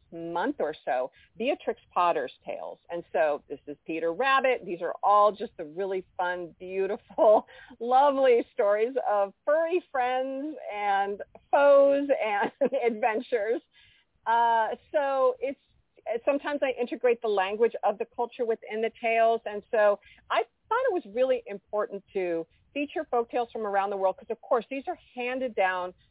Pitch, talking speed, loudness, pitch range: 230 Hz, 150 wpm, -27 LUFS, 200-270 Hz